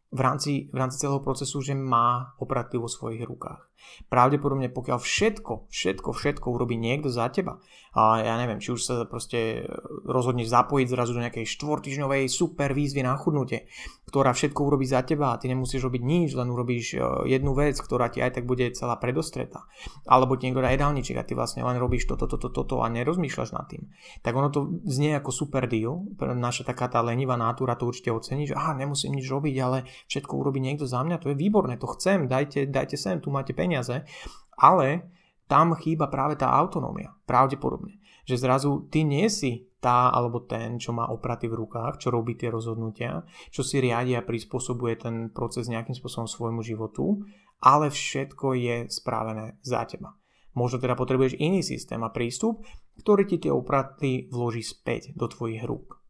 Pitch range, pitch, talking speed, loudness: 120-140 Hz, 130 Hz, 180 wpm, -26 LUFS